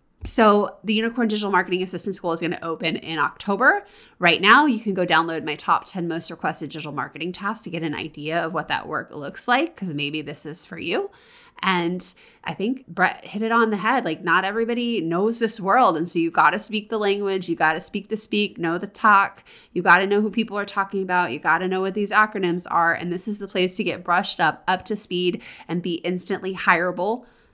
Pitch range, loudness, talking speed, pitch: 170-215 Hz, -22 LUFS, 230 wpm, 185 Hz